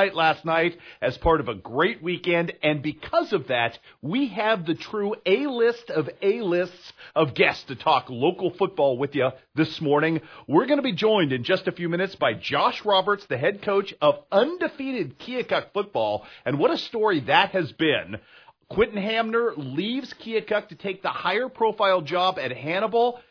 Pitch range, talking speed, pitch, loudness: 165-230 Hz, 170 wpm, 195 Hz, -24 LUFS